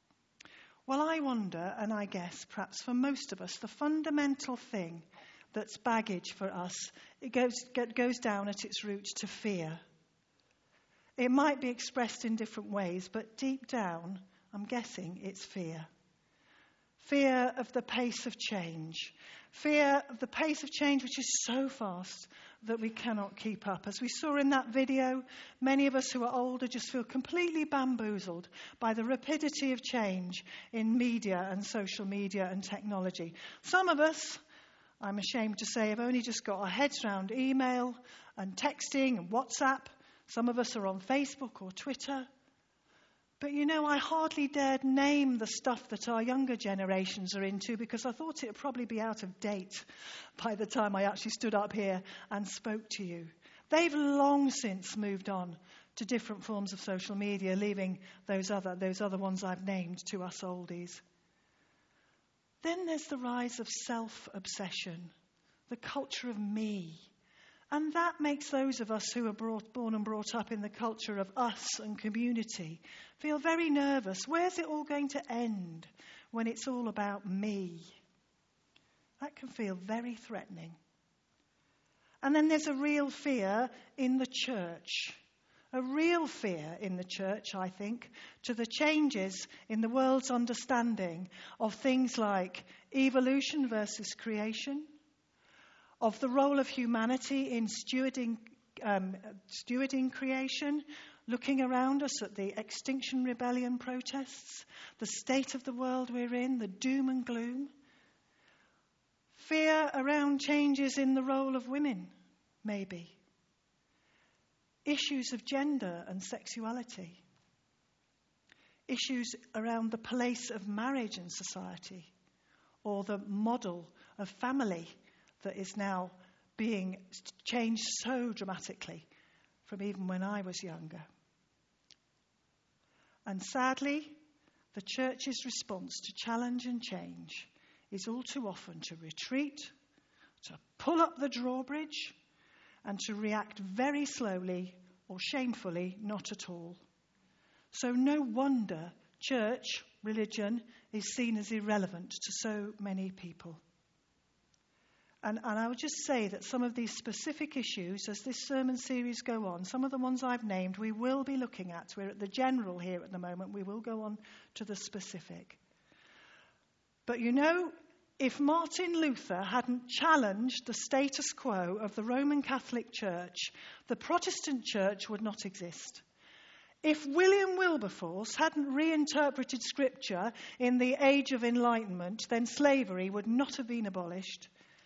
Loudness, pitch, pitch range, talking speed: -35 LUFS, 230 Hz, 195-265 Hz, 145 wpm